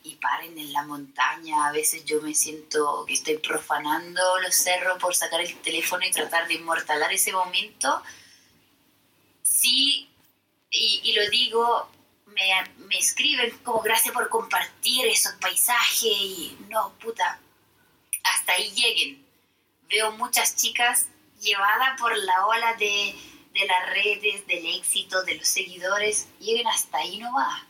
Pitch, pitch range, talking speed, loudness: 205 Hz, 170-245 Hz, 145 wpm, -23 LUFS